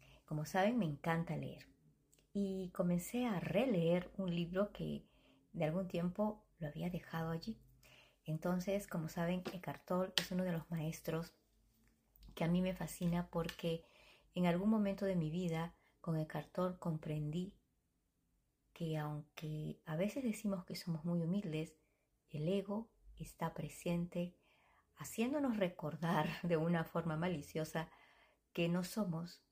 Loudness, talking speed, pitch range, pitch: -41 LUFS, 135 wpm, 155-185 Hz, 170 Hz